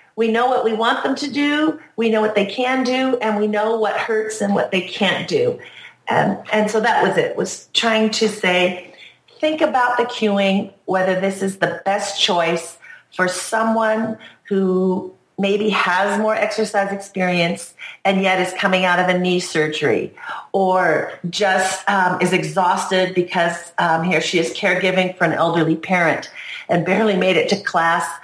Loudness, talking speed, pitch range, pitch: -18 LUFS, 175 wpm, 180-220 Hz, 195 Hz